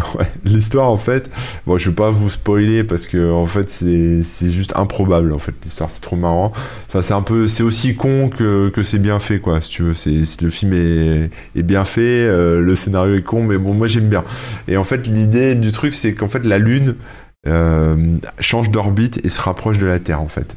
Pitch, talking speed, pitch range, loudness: 100 Hz, 235 wpm, 85-110 Hz, -16 LUFS